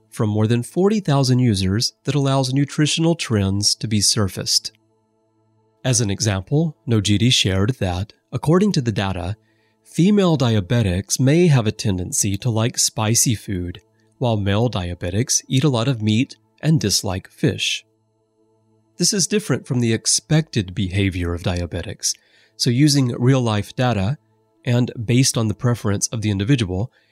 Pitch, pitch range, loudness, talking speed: 110 Hz, 105-135 Hz, -19 LUFS, 145 wpm